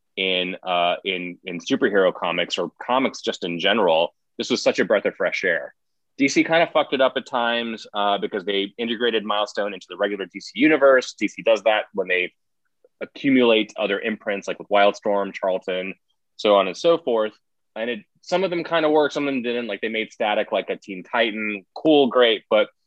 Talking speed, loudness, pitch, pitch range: 200 wpm, -21 LUFS, 115 Hz, 100-155 Hz